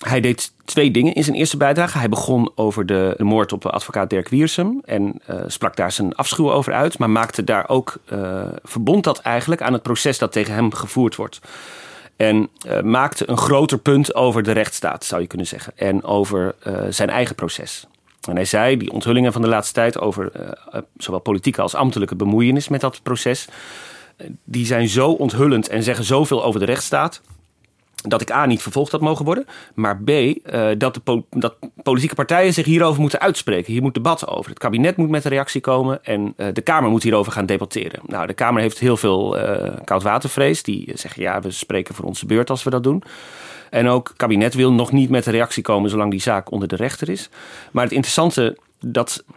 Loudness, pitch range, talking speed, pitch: -19 LUFS, 105-140 Hz, 205 wpm, 120 Hz